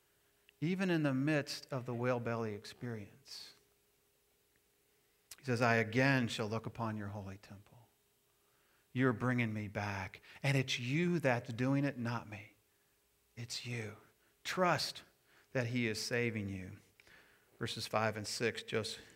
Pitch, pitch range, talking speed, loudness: 120 Hz, 110-130 Hz, 140 wpm, -37 LUFS